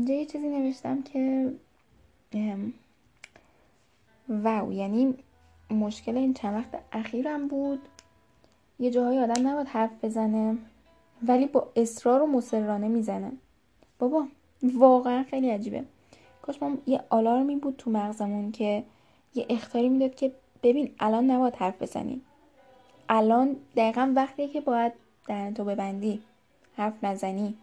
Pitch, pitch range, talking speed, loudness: 245 Hz, 220-265 Hz, 120 wpm, -27 LUFS